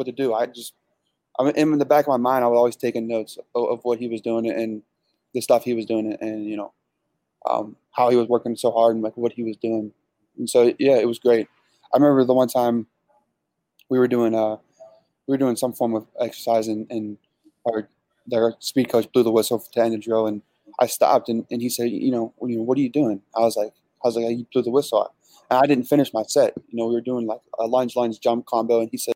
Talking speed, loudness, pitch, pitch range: 255 wpm, -22 LUFS, 120 Hz, 115-125 Hz